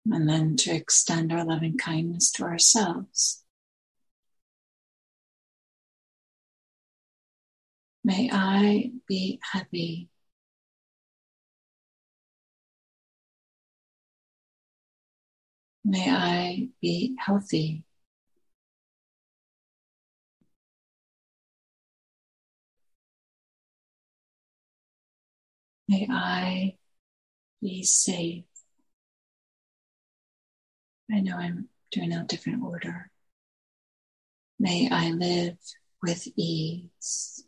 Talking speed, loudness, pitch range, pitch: 55 wpm, -26 LUFS, 170-210 Hz, 180 Hz